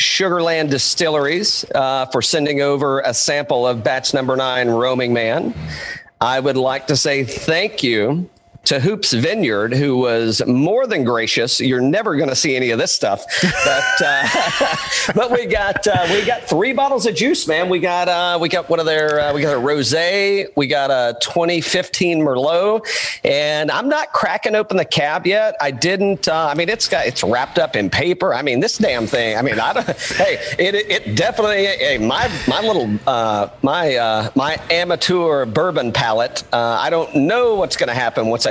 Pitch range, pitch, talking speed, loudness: 130-185 Hz, 155 Hz, 190 wpm, -17 LUFS